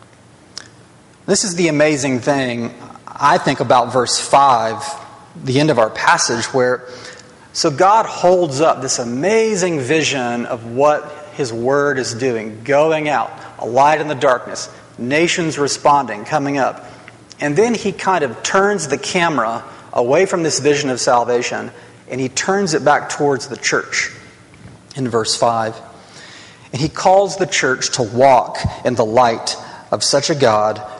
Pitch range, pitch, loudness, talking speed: 125-160 Hz, 140 Hz, -16 LUFS, 155 wpm